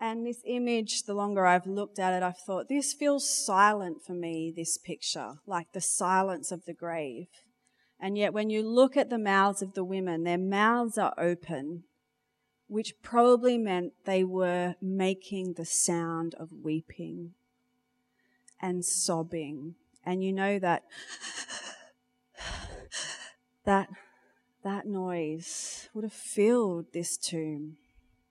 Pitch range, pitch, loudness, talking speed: 170-230 Hz, 190 Hz, -30 LUFS, 135 wpm